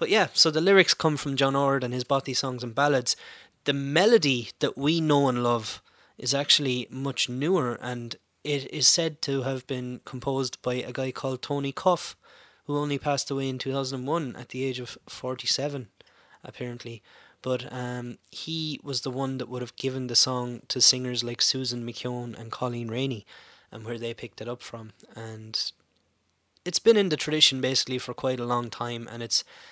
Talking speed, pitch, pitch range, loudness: 190 wpm, 130 Hz, 120-140 Hz, -26 LUFS